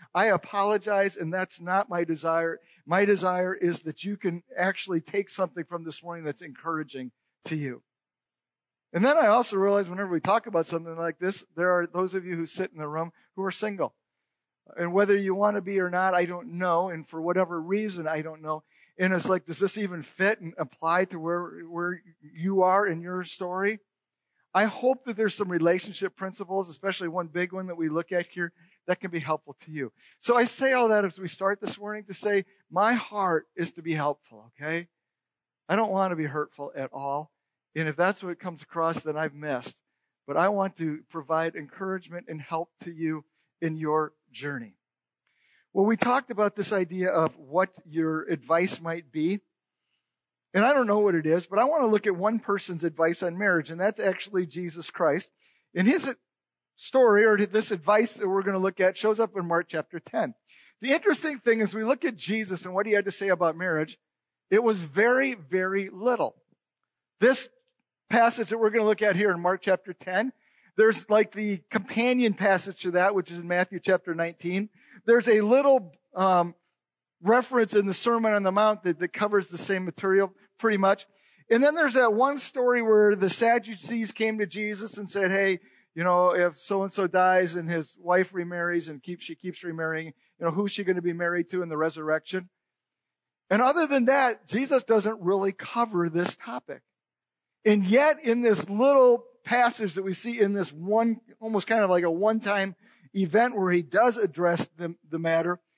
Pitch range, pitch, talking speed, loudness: 170-210 Hz, 185 Hz, 200 wpm, -26 LUFS